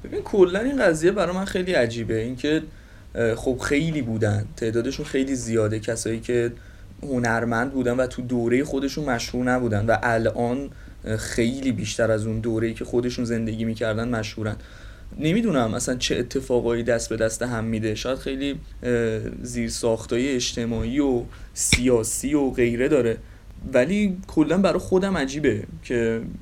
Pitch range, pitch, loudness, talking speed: 110-135 Hz, 120 Hz, -23 LUFS, 140 wpm